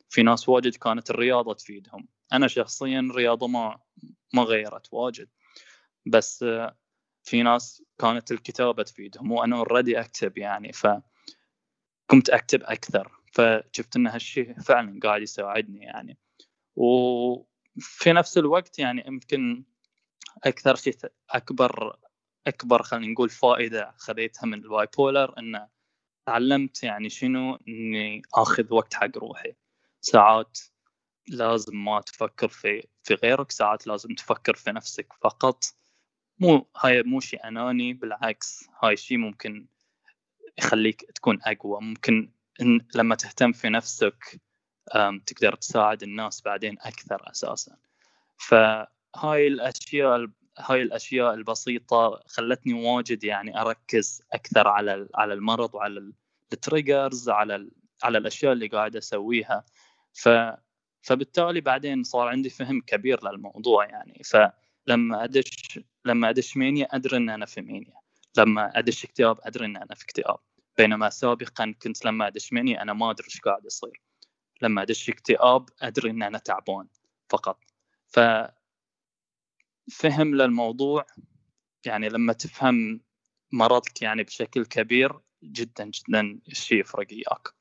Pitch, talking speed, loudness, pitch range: 120 Hz, 120 wpm, -24 LUFS, 110-130 Hz